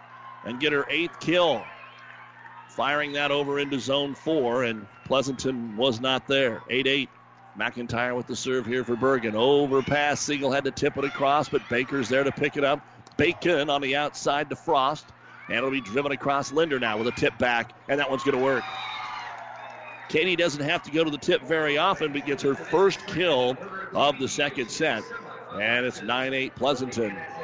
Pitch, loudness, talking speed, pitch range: 140 Hz, -25 LUFS, 185 wpm, 130-145 Hz